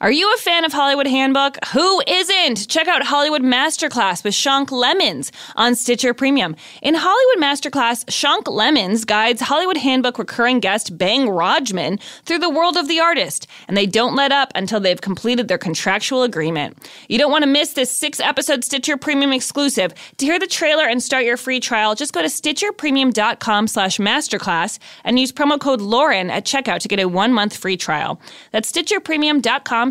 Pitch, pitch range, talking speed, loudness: 265 Hz, 220-300 Hz, 175 wpm, -17 LUFS